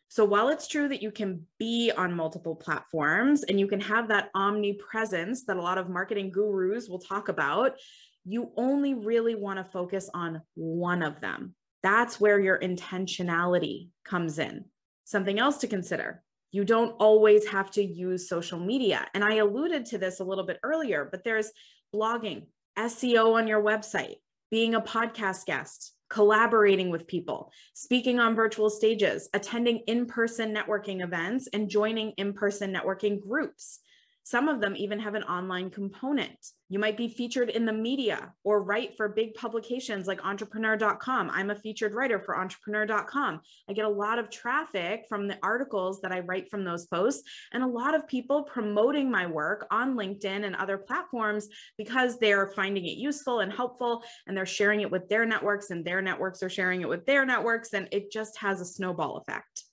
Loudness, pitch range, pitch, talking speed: -28 LUFS, 190-230 Hz, 210 Hz, 180 wpm